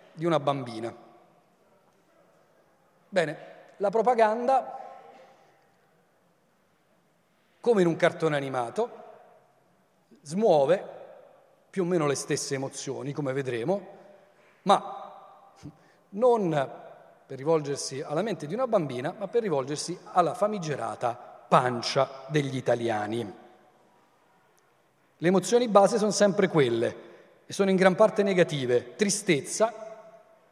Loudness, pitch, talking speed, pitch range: -26 LUFS, 185 Hz, 100 wpm, 140-210 Hz